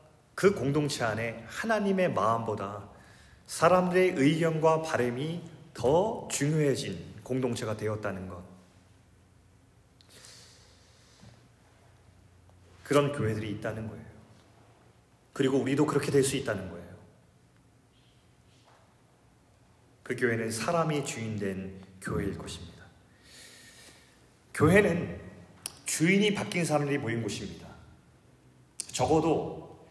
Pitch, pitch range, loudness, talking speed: 115 Hz, 100-145 Hz, -29 LUFS, 210 characters per minute